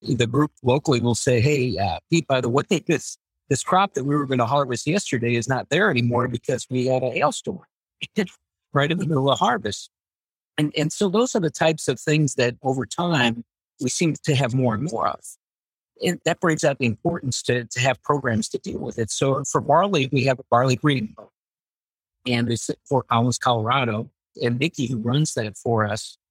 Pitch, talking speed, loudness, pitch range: 130 Hz, 210 wpm, -22 LUFS, 120-150 Hz